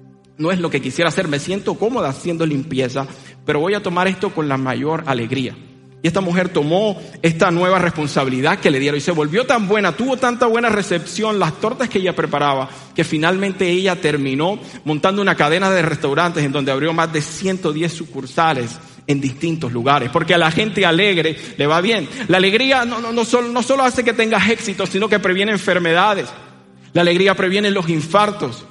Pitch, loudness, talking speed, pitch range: 170 Hz, -17 LUFS, 190 wpm, 145-200 Hz